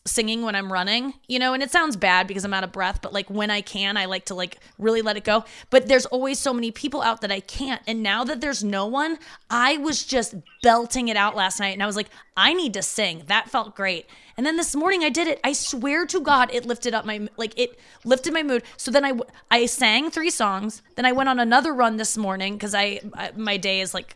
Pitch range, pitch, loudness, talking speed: 205-265 Hz, 230 Hz, -22 LUFS, 260 wpm